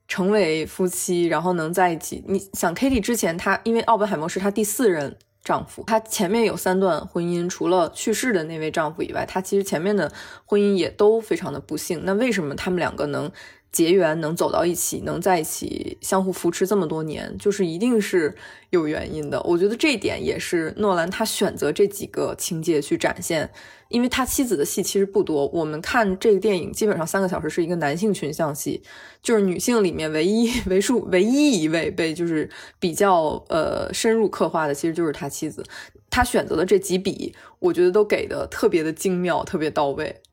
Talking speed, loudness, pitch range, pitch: 315 characters per minute, -22 LUFS, 175-225 Hz, 195 Hz